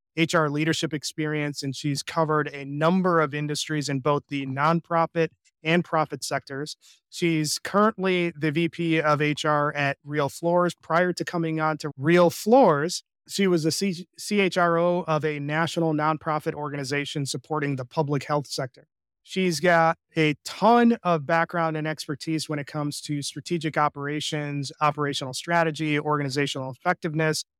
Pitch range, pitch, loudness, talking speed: 145-170 Hz, 155 Hz, -25 LUFS, 145 wpm